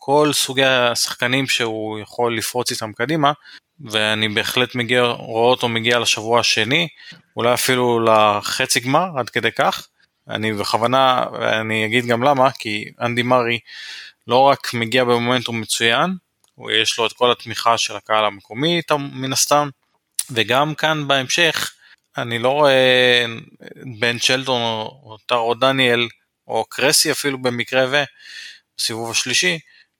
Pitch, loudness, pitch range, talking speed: 125 Hz, -18 LUFS, 115-135 Hz, 130 wpm